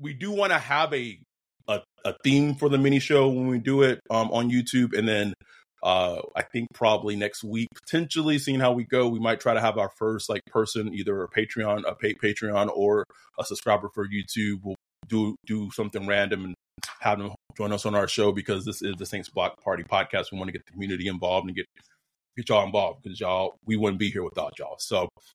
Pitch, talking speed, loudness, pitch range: 105 Hz, 225 wpm, -26 LUFS, 100-125 Hz